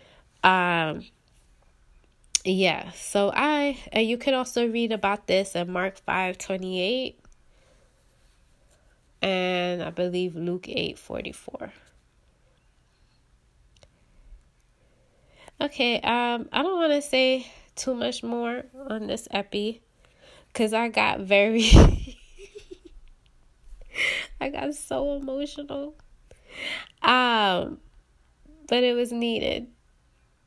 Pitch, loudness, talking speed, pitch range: 220 Hz, -25 LUFS, 95 wpm, 180-260 Hz